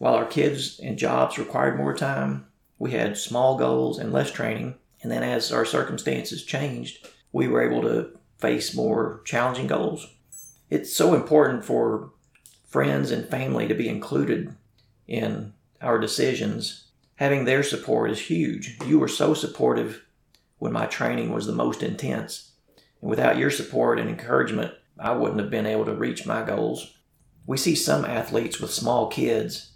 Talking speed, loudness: 160 wpm, -25 LUFS